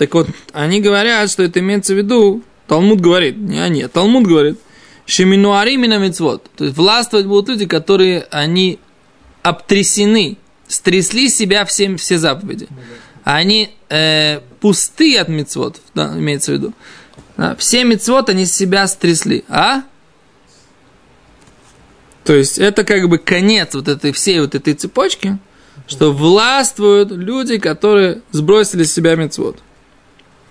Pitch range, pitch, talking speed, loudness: 160-210 Hz, 190 Hz, 135 wpm, -13 LUFS